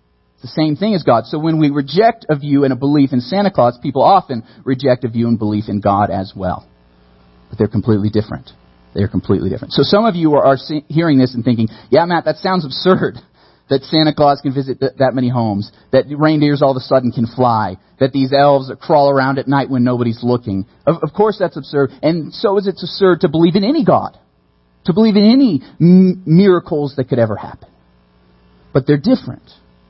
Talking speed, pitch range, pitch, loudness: 210 wpm, 105-155 Hz, 135 Hz, -14 LUFS